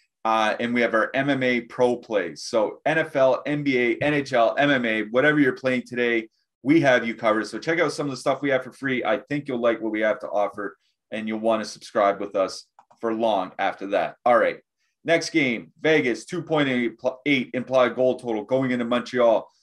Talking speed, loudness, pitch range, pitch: 195 wpm, -23 LUFS, 115-140 Hz, 125 Hz